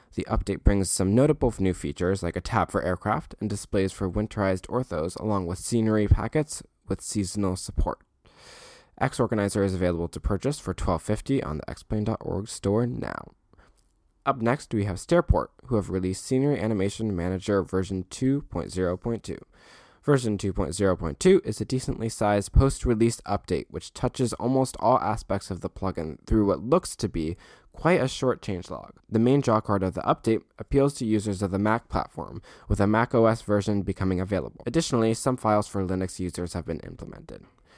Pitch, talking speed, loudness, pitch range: 105 Hz, 175 wpm, -26 LUFS, 95-115 Hz